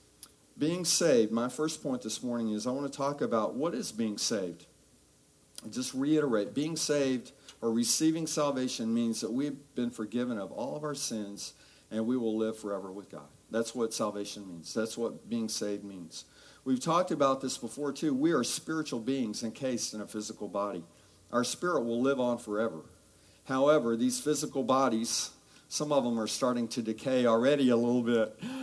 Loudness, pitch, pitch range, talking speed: -31 LUFS, 120 Hz, 110-140 Hz, 180 wpm